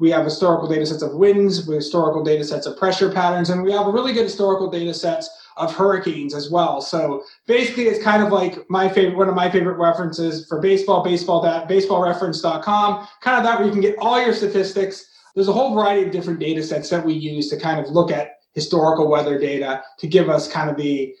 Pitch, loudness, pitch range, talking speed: 175 Hz, -19 LUFS, 155-195 Hz, 230 wpm